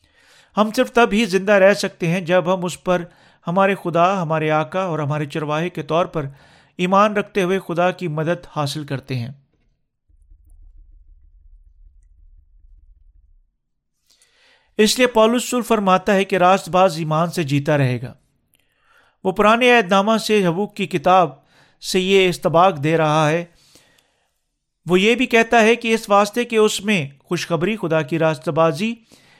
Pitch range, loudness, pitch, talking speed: 145-200 Hz, -18 LUFS, 175 Hz, 150 wpm